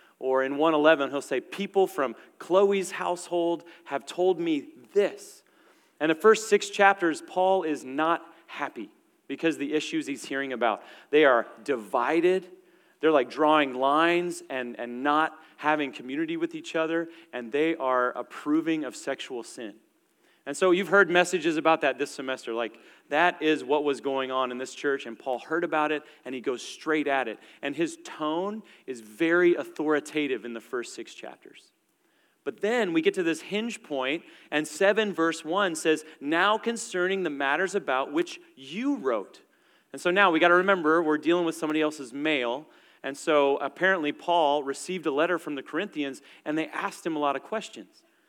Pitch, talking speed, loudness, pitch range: 160 Hz, 180 wpm, -26 LUFS, 140-195 Hz